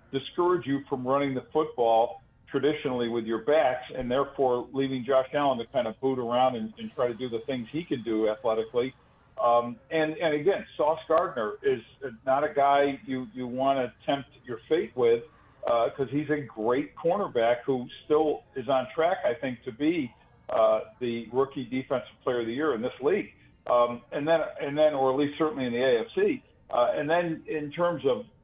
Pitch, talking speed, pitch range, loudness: 135 Hz, 195 wpm, 120-155 Hz, -28 LUFS